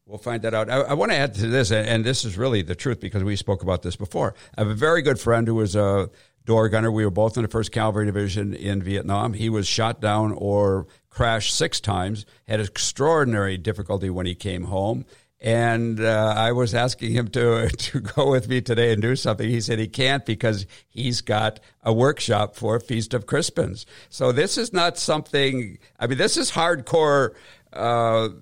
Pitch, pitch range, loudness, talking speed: 115 Hz, 105-125 Hz, -22 LUFS, 205 wpm